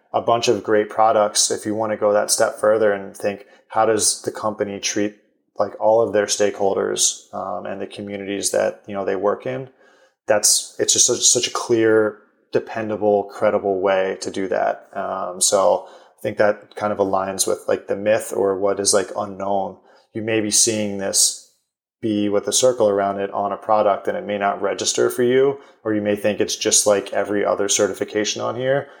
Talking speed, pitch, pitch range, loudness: 205 wpm, 105 Hz, 100-110 Hz, -19 LUFS